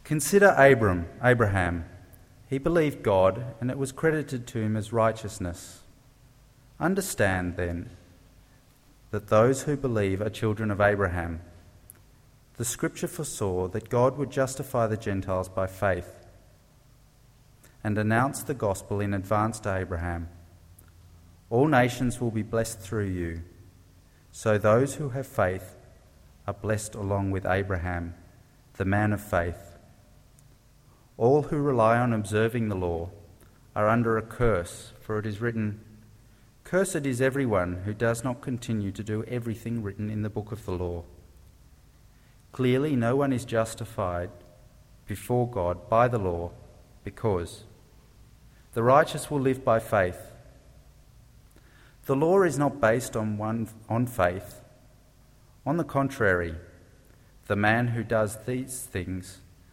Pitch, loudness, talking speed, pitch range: 110 Hz, -27 LUFS, 130 wpm, 95-125 Hz